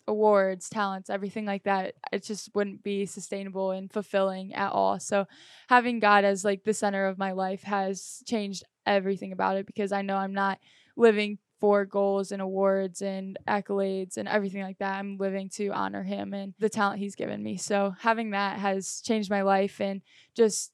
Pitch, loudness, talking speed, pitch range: 195 Hz, -28 LUFS, 190 wpm, 190-205 Hz